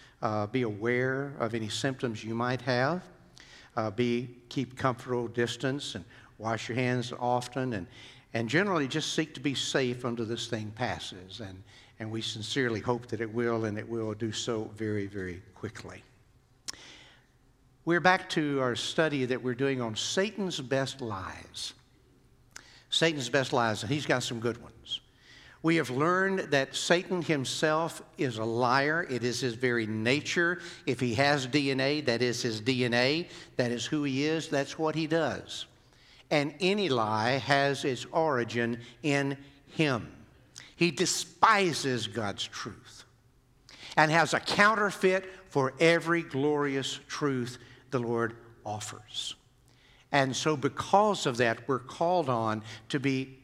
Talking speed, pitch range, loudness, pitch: 150 wpm, 120-145 Hz, -29 LUFS, 130 Hz